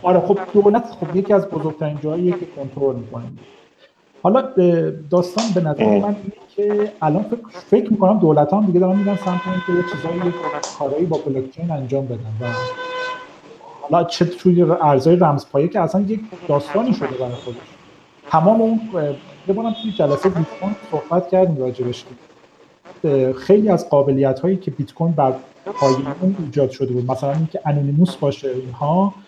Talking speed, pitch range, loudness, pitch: 155 wpm, 140-195 Hz, -18 LUFS, 175 Hz